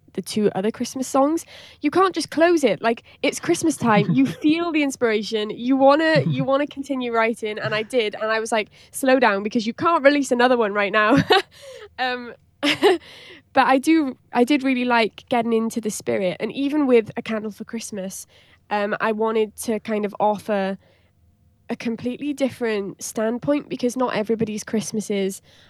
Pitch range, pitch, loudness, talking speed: 215-270 Hz, 230 Hz, -21 LUFS, 175 wpm